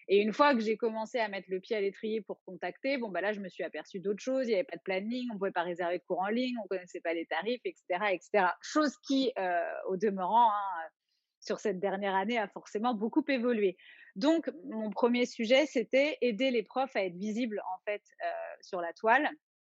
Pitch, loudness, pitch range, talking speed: 220 Hz, -32 LUFS, 190-255 Hz, 235 wpm